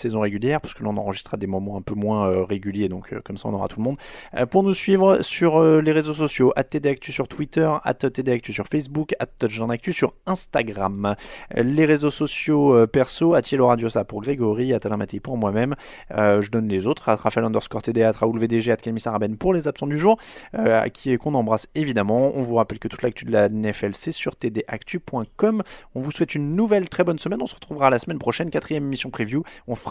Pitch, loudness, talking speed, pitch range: 125 Hz, -22 LUFS, 235 wpm, 110-150 Hz